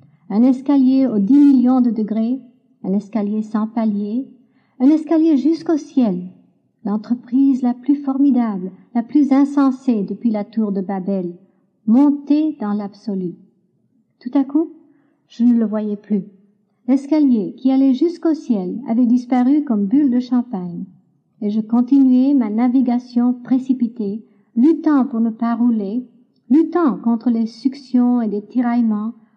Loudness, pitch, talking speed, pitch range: -17 LUFS, 240 Hz, 135 wpm, 210-270 Hz